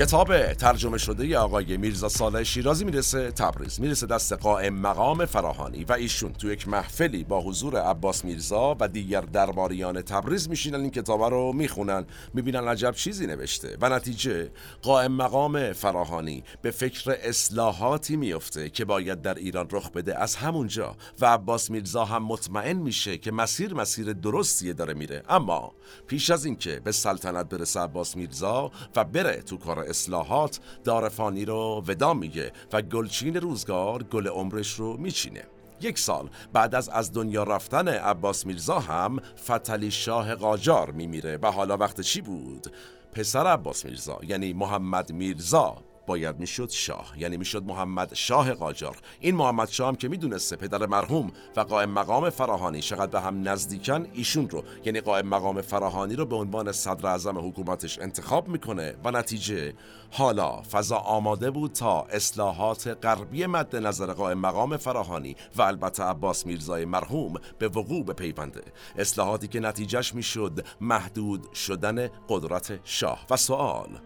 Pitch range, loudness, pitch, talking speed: 95-125 Hz, -27 LUFS, 105 Hz, 150 wpm